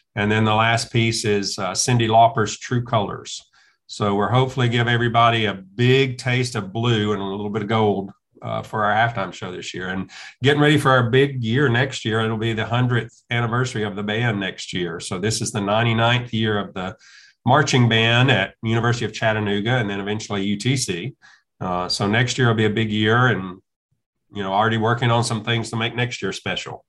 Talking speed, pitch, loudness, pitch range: 210 wpm, 115 Hz, -20 LUFS, 105-120 Hz